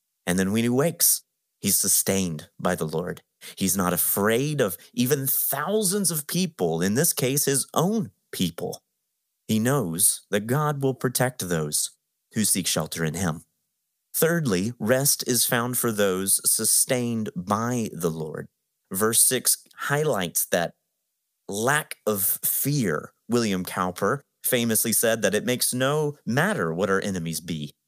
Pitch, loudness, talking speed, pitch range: 115 Hz, -23 LUFS, 140 wpm, 95-135 Hz